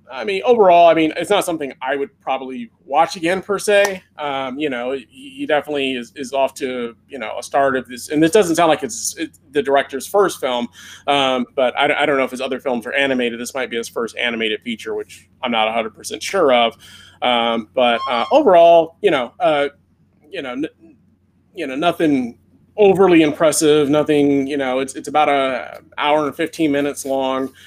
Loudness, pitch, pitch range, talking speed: -17 LUFS, 140 Hz, 125-160 Hz, 200 wpm